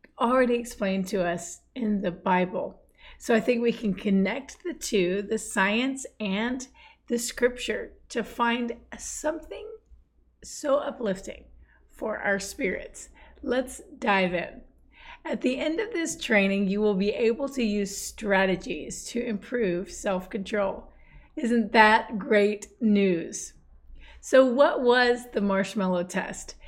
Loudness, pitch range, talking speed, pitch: -26 LUFS, 195-250 Hz, 130 wpm, 220 Hz